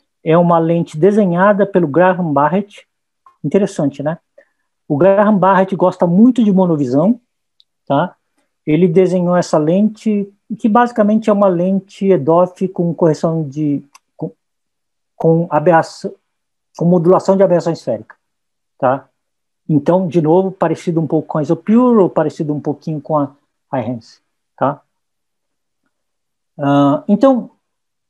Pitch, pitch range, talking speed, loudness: 180 Hz, 160-195 Hz, 125 wpm, -14 LUFS